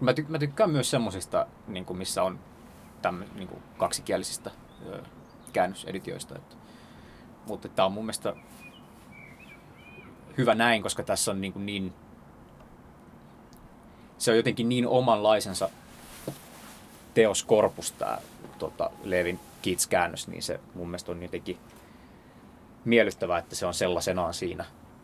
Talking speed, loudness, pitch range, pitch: 100 wpm, -28 LUFS, 90-120 Hz, 100 Hz